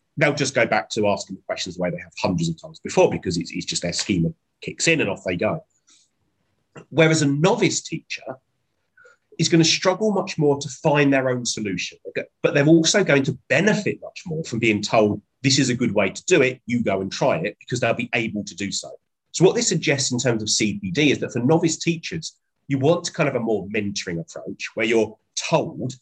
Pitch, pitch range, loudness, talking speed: 140 Hz, 120-165 Hz, -21 LUFS, 225 wpm